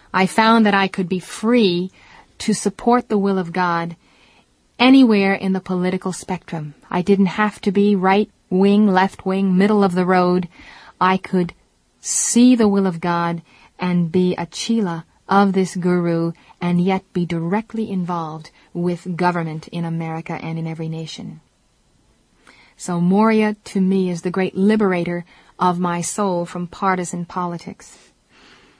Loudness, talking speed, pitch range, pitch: -18 LUFS, 150 wpm, 175-200 Hz, 185 Hz